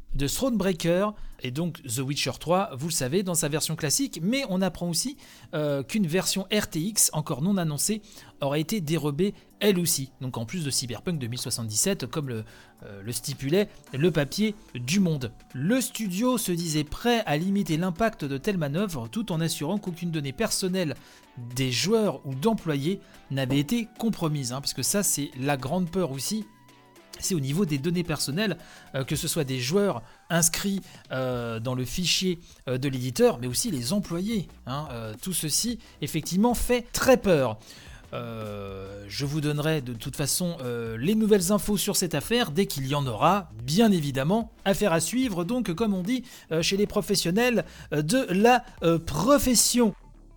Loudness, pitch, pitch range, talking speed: -26 LUFS, 165 Hz, 135-205 Hz, 165 wpm